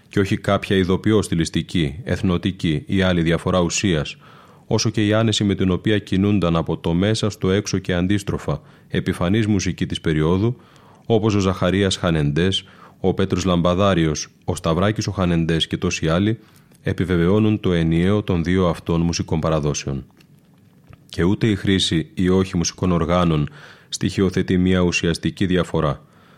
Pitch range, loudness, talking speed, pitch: 85-100 Hz, -20 LUFS, 145 wpm, 95 Hz